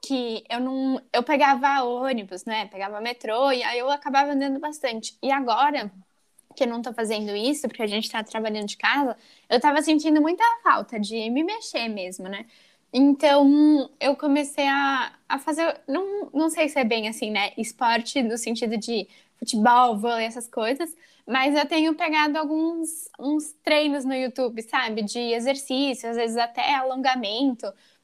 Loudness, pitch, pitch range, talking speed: -23 LUFS, 265 Hz, 230-295 Hz, 165 wpm